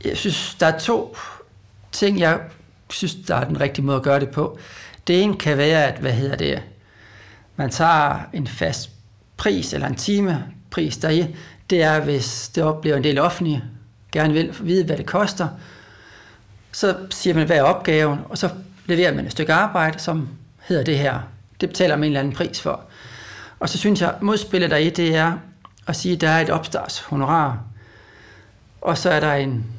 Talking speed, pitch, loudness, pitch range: 185 wpm, 155 Hz, -20 LUFS, 120-175 Hz